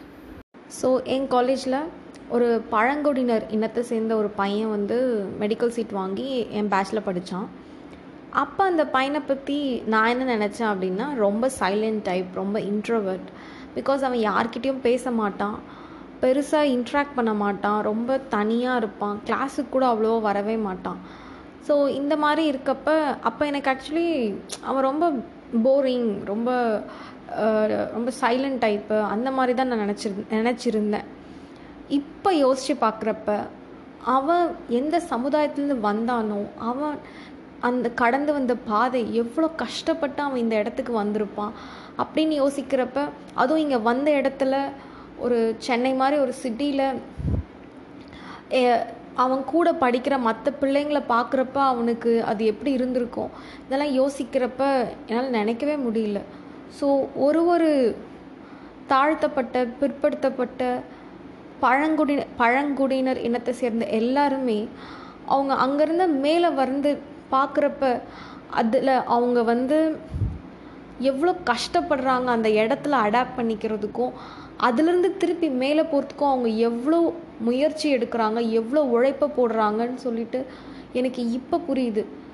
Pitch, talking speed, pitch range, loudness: 255 Hz, 110 wpm, 230-285 Hz, -23 LUFS